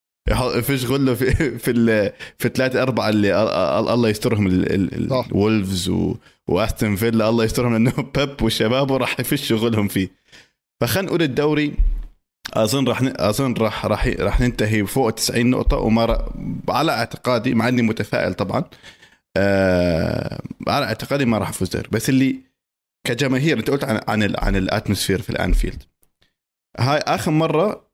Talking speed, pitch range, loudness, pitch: 135 wpm, 105-130 Hz, -20 LUFS, 115 Hz